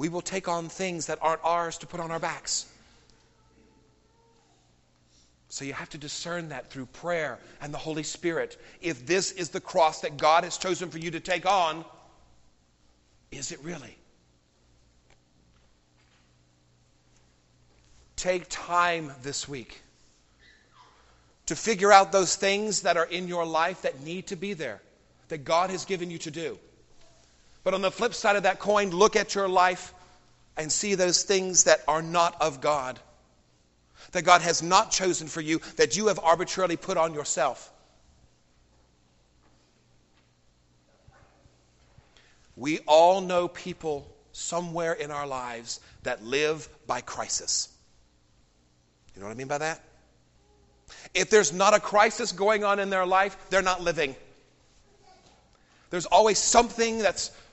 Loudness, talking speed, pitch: -26 LUFS, 145 wpm, 160 Hz